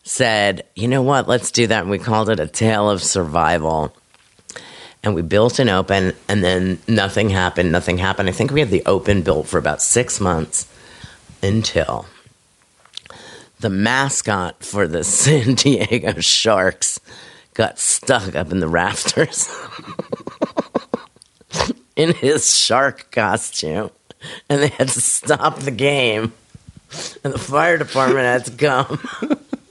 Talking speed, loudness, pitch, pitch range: 140 wpm, -17 LUFS, 115 Hz, 95-135 Hz